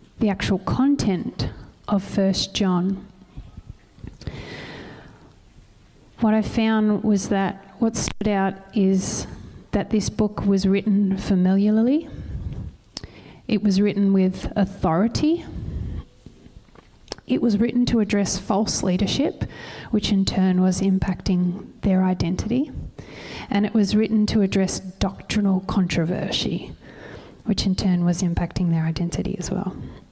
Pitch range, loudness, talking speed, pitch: 185-210 Hz, -22 LUFS, 115 wpm, 195 Hz